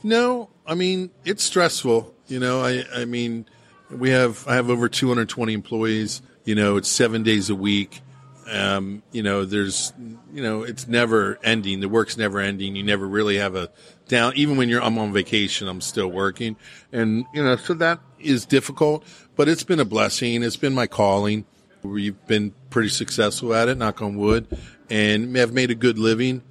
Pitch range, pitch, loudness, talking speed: 105-130 Hz, 115 Hz, -22 LUFS, 195 wpm